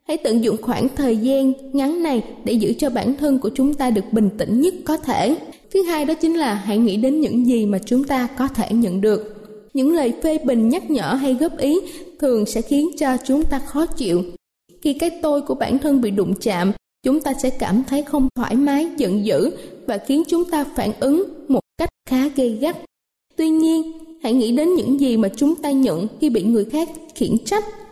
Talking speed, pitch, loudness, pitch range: 220 wpm, 270 Hz, -19 LUFS, 230-310 Hz